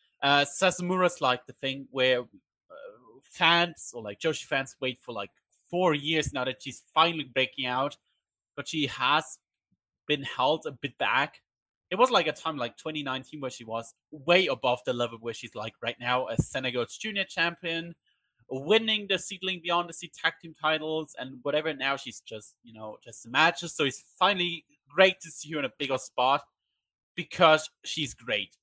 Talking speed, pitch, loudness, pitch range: 180 wpm, 145 Hz, -28 LUFS, 130-170 Hz